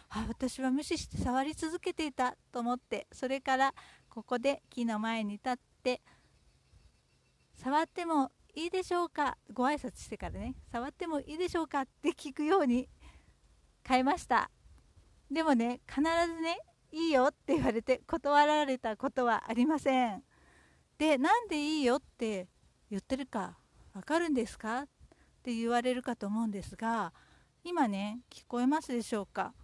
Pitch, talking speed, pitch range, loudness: 265 Hz, 300 characters per minute, 240-305 Hz, -33 LUFS